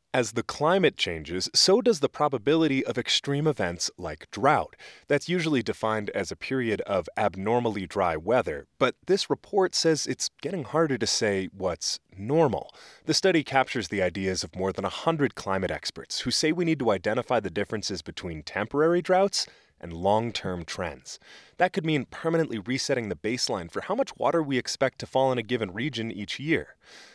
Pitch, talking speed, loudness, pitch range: 125 Hz, 180 wpm, -26 LUFS, 100-155 Hz